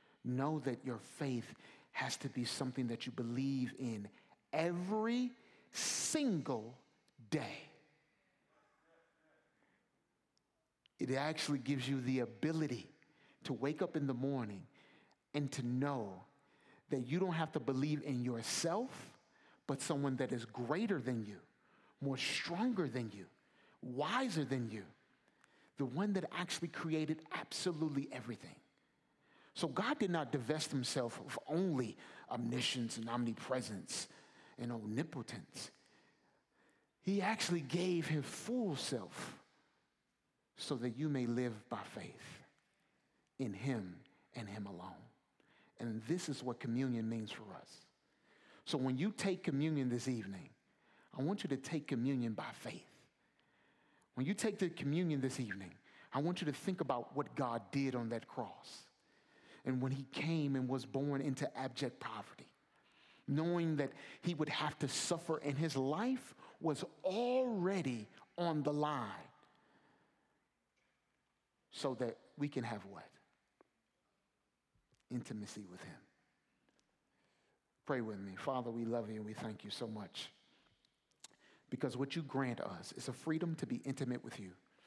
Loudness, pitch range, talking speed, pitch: -41 LUFS, 120-155 Hz, 135 wpm, 135 Hz